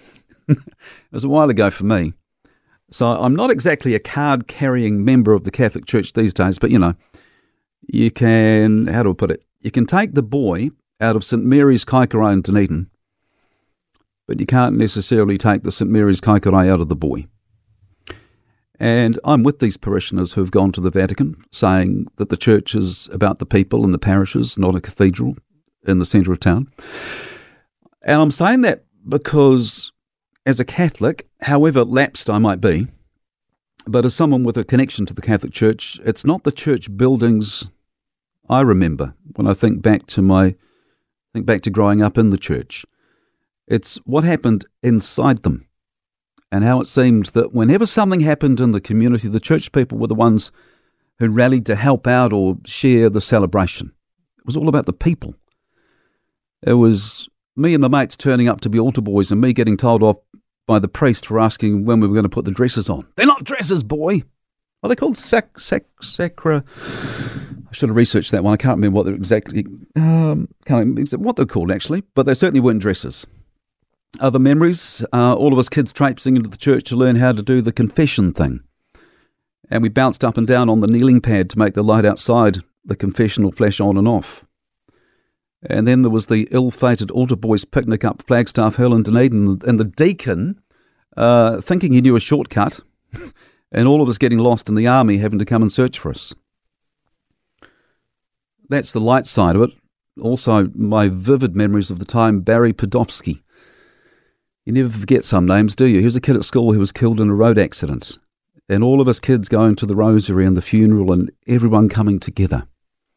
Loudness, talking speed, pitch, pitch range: -16 LUFS, 190 wpm, 115 Hz, 105-130 Hz